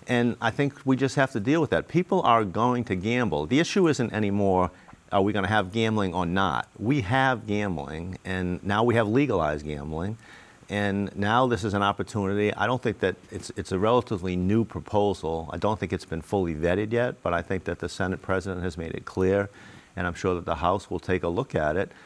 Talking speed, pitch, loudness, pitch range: 225 wpm, 100 Hz, -26 LUFS, 90-115 Hz